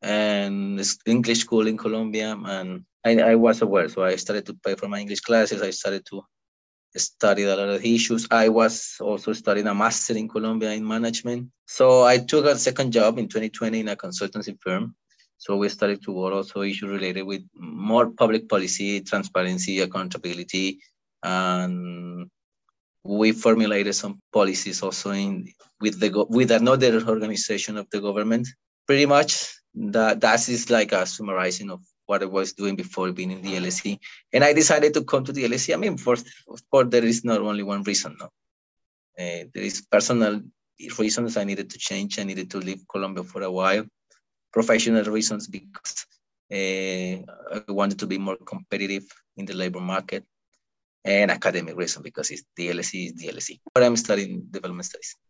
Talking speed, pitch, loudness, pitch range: 175 wpm, 105 Hz, -23 LUFS, 95-115 Hz